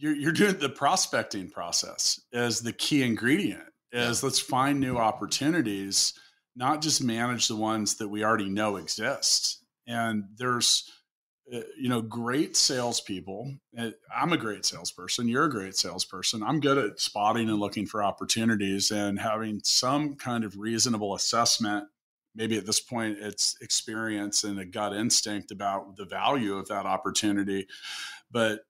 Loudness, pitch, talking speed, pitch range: -27 LUFS, 110 Hz, 145 wpm, 105-120 Hz